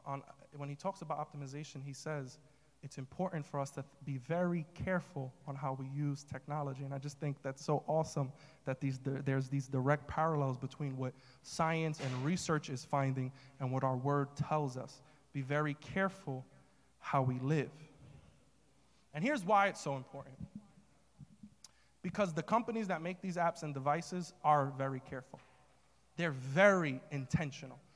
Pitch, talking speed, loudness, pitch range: 145 Hz, 160 wpm, -37 LUFS, 135-160 Hz